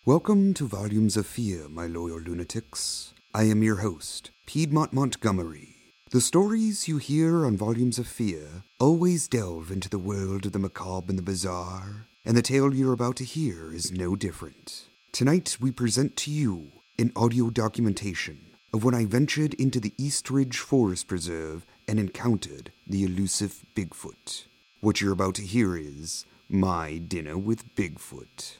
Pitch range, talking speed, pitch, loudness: 95-130 Hz, 160 wpm, 110 Hz, -27 LUFS